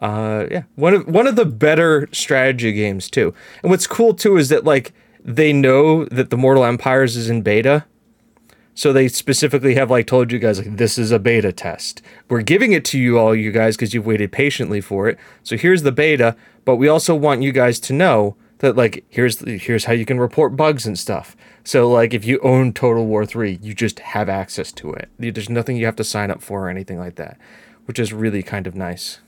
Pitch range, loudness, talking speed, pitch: 110-140 Hz, -16 LUFS, 225 wpm, 120 Hz